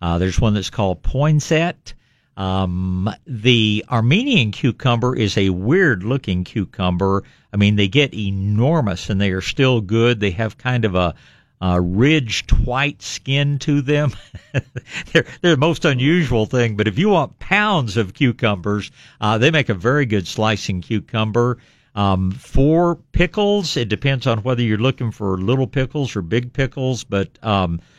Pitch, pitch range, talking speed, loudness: 115 Hz, 100-140 Hz, 160 wpm, -18 LUFS